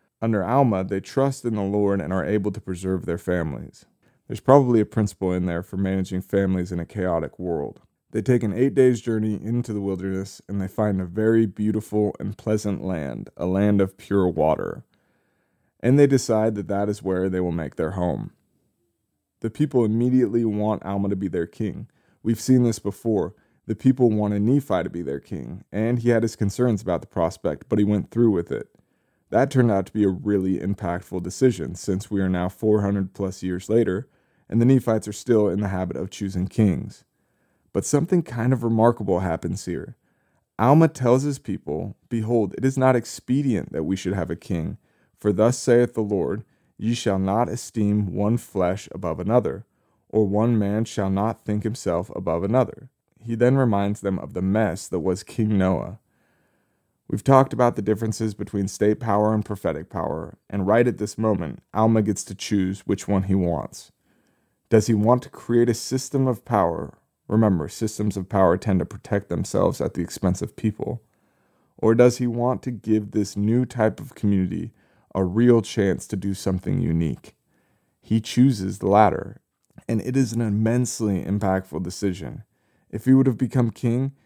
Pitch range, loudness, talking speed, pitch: 95-120 Hz, -23 LUFS, 185 wpm, 105 Hz